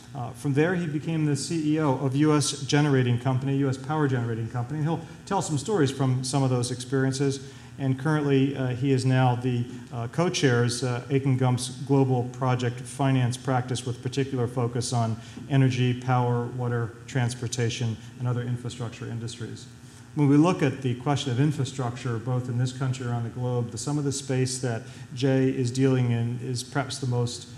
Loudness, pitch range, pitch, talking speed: -26 LUFS, 120-135 Hz, 130 Hz, 180 wpm